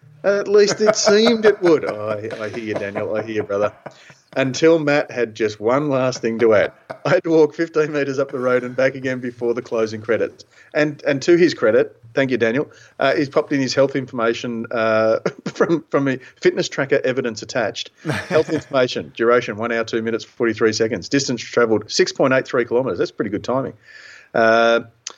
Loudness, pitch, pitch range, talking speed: -19 LUFS, 130 Hz, 115-155 Hz, 195 wpm